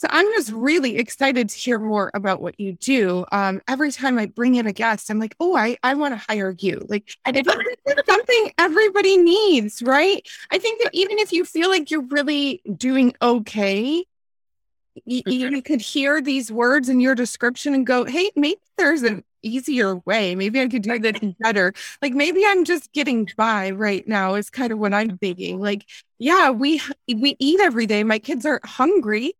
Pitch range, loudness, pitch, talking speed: 215-305 Hz, -20 LUFS, 255 Hz, 195 wpm